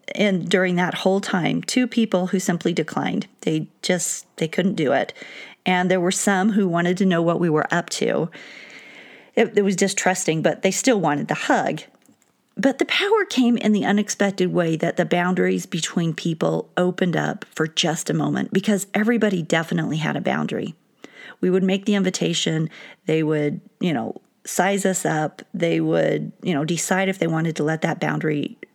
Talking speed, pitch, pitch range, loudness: 185 wpm, 185 Hz, 165-200 Hz, -21 LUFS